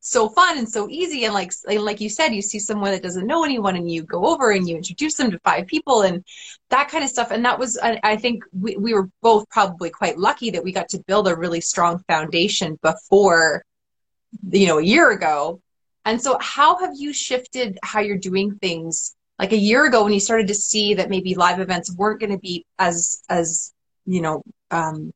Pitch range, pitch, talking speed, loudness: 180-230 Hz, 205 Hz, 220 wpm, -19 LUFS